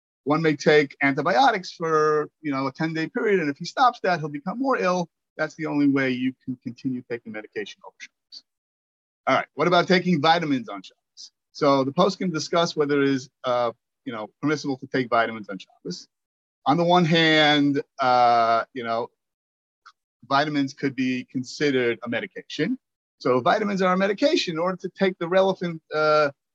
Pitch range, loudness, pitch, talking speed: 125-175 Hz, -23 LUFS, 145 Hz, 185 wpm